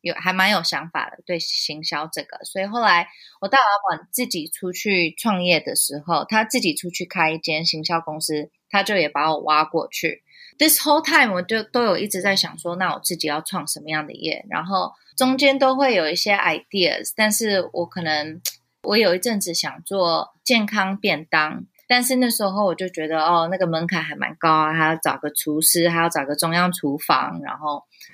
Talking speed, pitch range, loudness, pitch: 310 characters per minute, 160-210 Hz, -20 LUFS, 175 Hz